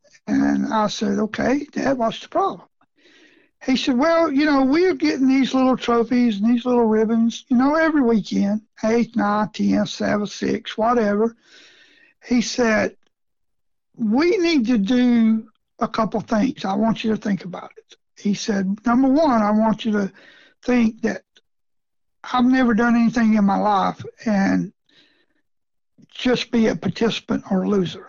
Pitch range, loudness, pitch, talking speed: 215-265 Hz, -20 LUFS, 235 Hz, 155 wpm